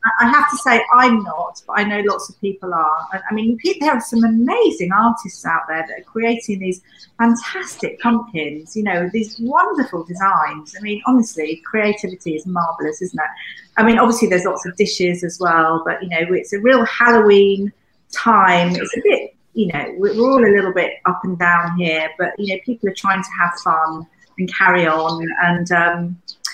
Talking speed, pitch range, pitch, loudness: 195 wpm, 175-230 Hz, 195 Hz, -17 LUFS